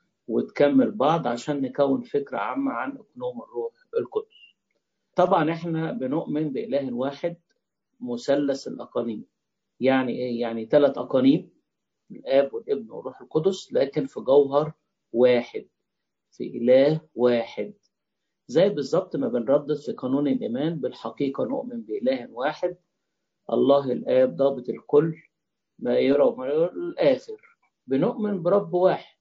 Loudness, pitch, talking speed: -24 LUFS, 160 Hz, 115 wpm